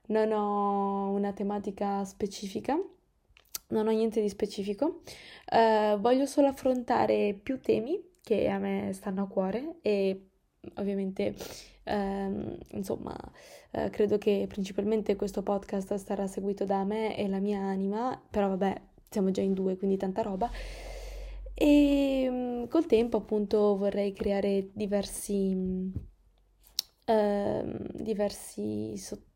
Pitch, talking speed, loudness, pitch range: 205 Hz, 125 wpm, -30 LUFS, 195-225 Hz